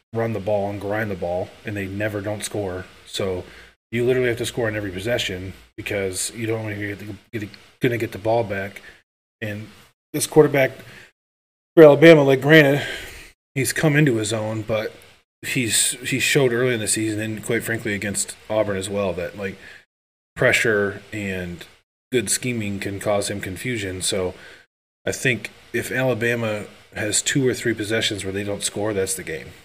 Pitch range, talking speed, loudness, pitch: 100-115 Hz, 180 wpm, -21 LUFS, 105 Hz